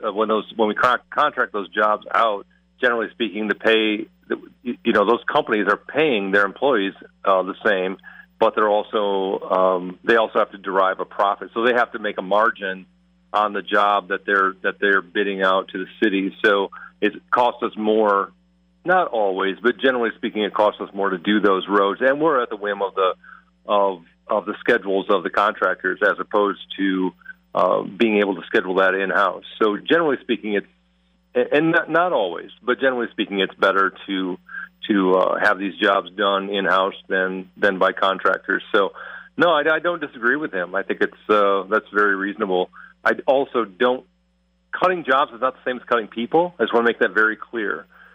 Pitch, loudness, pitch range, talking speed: 100 Hz, -20 LUFS, 95-110 Hz, 195 wpm